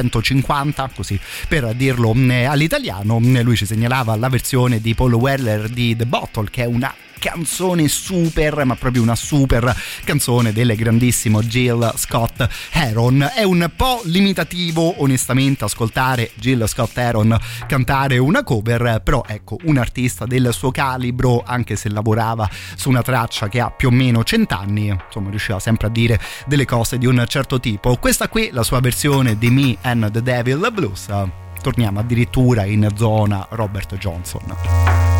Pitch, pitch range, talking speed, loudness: 120 Hz, 110-135 Hz, 155 wpm, -17 LUFS